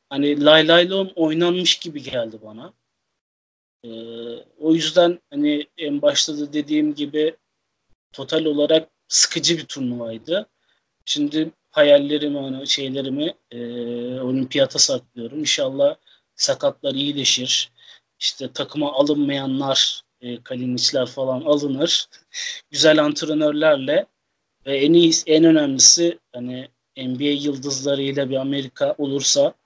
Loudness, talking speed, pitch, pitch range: -19 LUFS, 100 wpm, 145 Hz, 130-160 Hz